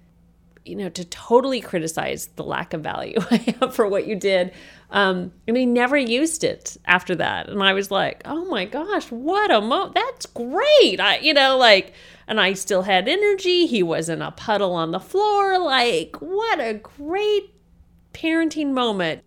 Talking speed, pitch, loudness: 180 wpm, 240 Hz, -20 LUFS